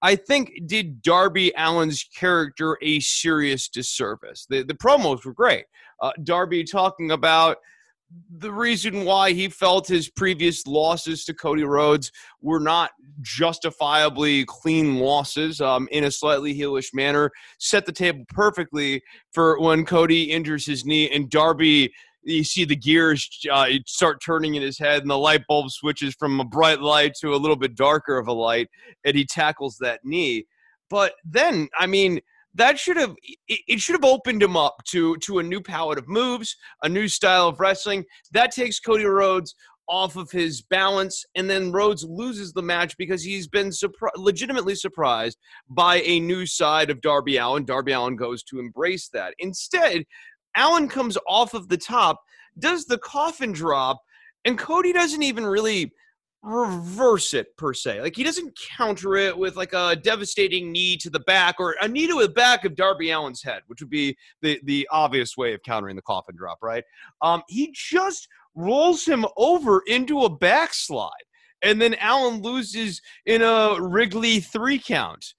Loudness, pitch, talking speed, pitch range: -21 LUFS, 175 Hz, 170 wpm, 150-215 Hz